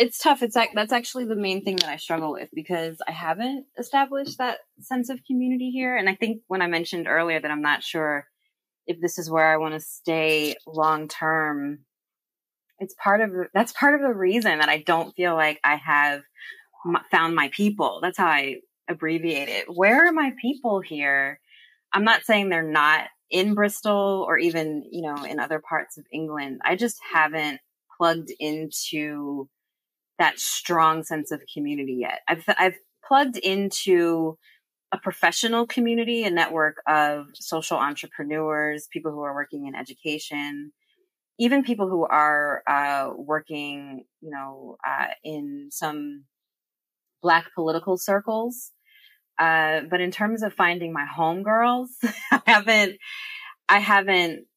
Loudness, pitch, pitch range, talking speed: -23 LUFS, 170 Hz, 150-220 Hz, 155 wpm